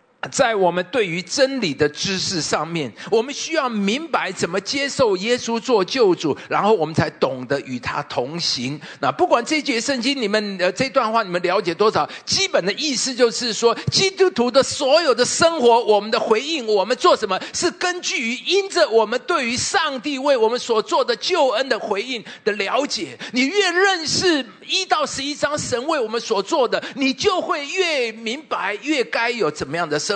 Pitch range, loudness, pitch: 205-310 Hz, -19 LUFS, 245 Hz